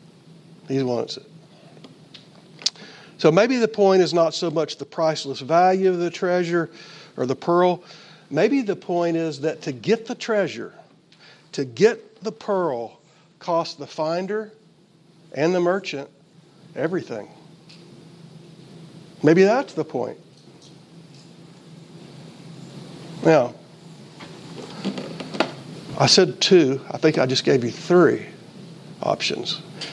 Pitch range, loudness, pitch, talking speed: 160-180 Hz, -21 LUFS, 170 Hz, 110 wpm